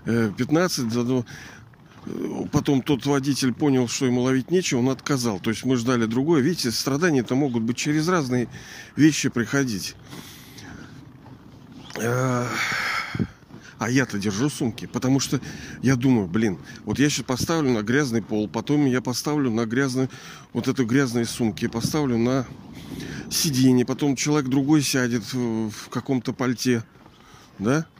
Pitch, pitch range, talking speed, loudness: 130 Hz, 120-140 Hz, 130 wpm, -23 LUFS